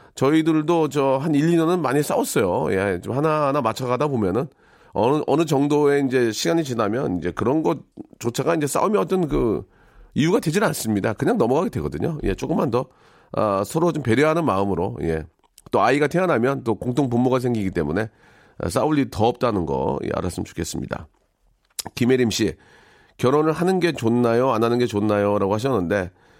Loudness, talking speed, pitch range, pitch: -21 LUFS, 370 characters per minute, 105-150 Hz, 125 Hz